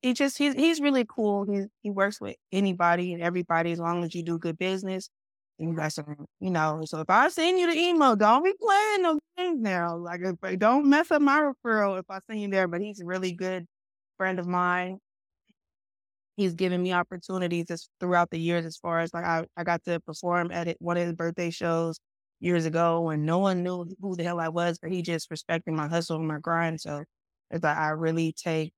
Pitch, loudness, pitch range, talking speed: 175 Hz, -27 LUFS, 165-195 Hz, 225 wpm